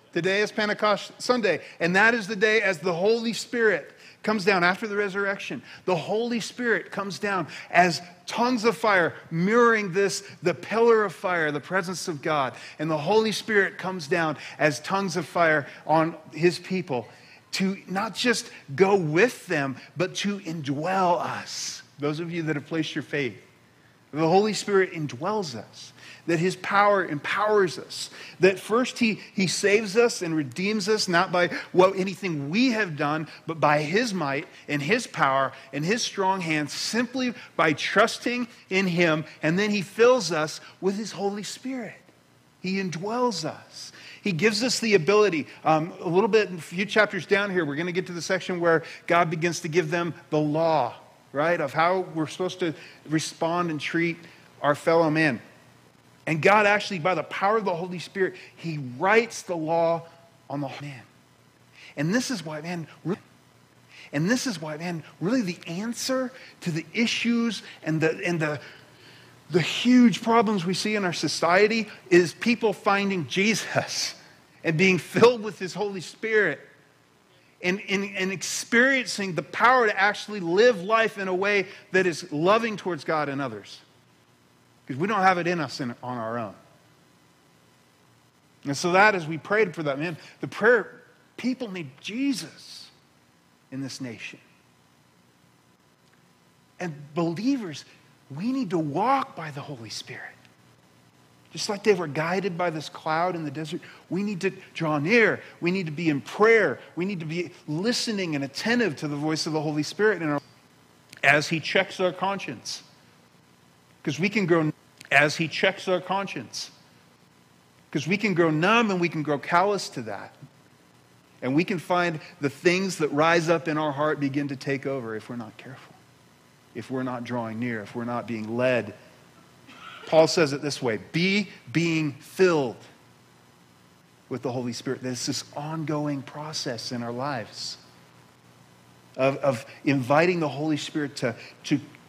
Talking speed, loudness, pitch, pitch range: 170 wpm, -25 LUFS, 175 Hz, 145-200 Hz